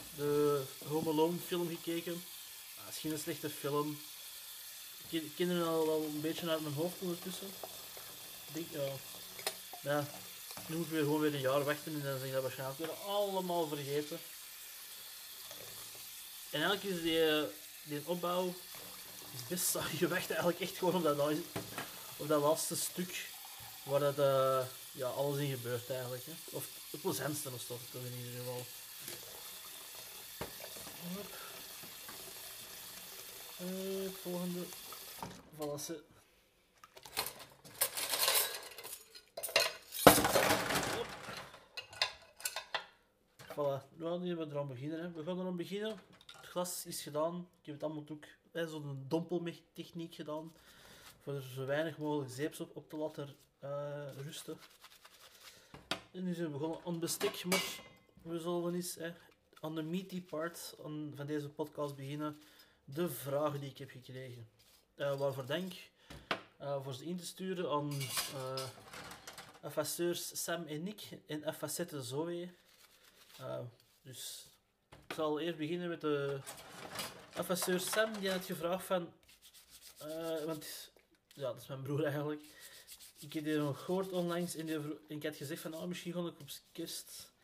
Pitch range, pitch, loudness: 145-175 Hz, 155 Hz, -38 LUFS